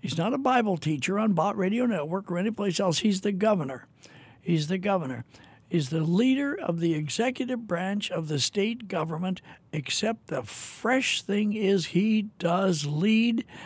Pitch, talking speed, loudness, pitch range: 190 Hz, 165 wpm, -27 LUFS, 160-215 Hz